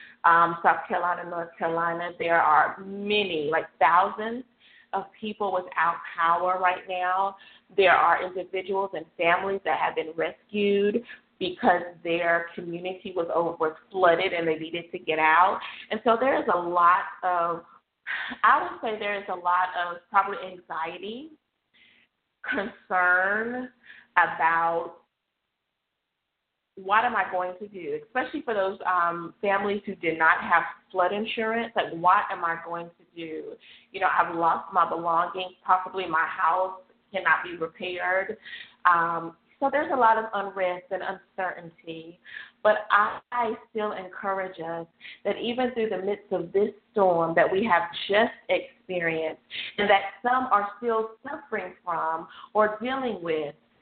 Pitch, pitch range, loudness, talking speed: 185 Hz, 170-210 Hz, -25 LUFS, 145 wpm